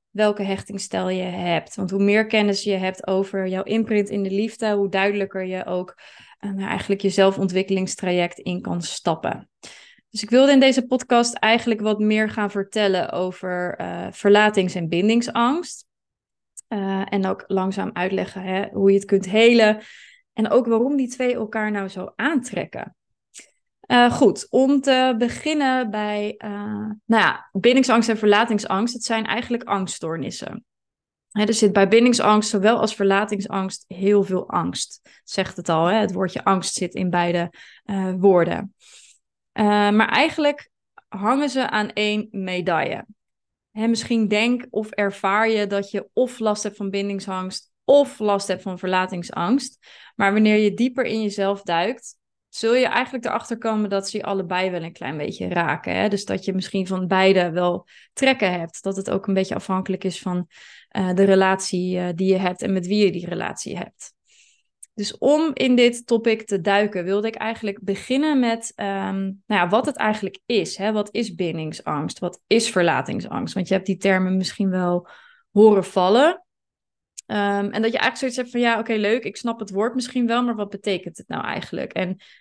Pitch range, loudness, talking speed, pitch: 190-230 Hz, -21 LUFS, 175 wpm, 205 Hz